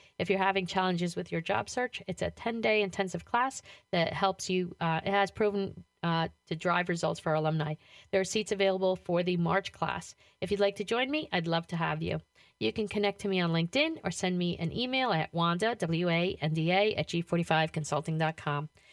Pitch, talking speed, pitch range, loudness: 180 Hz, 215 wpm, 165-200 Hz, -31 LUFS